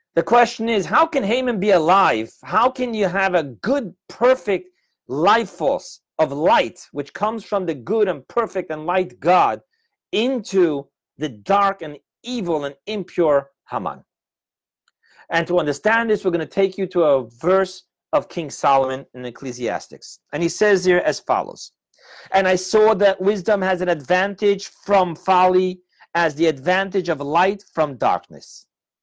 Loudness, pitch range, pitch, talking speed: -20 LUFS, 165-210 Hz, 185 Hz, 160 wpm